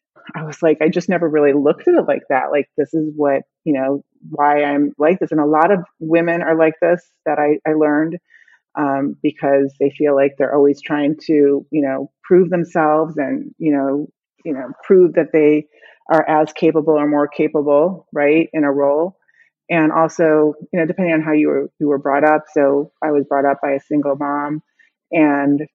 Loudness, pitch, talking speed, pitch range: -16 LUFS, 150 Hz, 205 wpm, 145-160 Hz